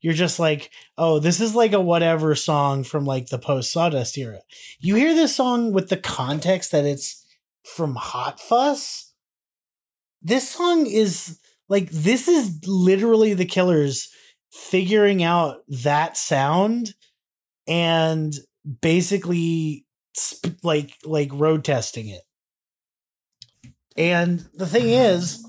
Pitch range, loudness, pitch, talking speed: 145-200 Hz, -21 LUFS, 170 Hz, 125 wpm